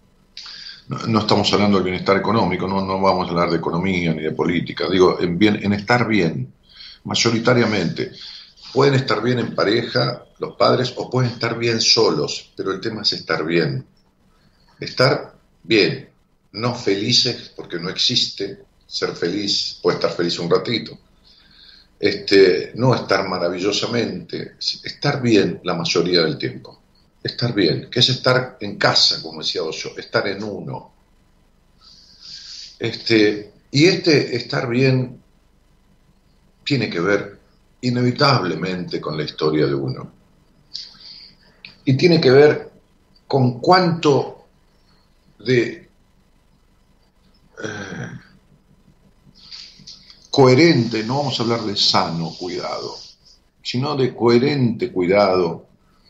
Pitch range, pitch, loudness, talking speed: 95-125 Hz, 115 Hz, -18 LUFS, 120 wpm